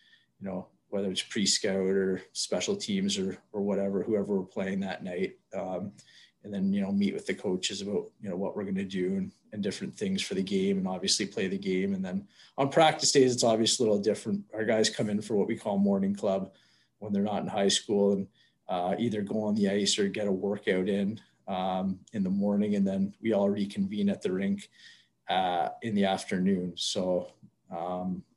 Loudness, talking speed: -29 LUFS, 215 wpm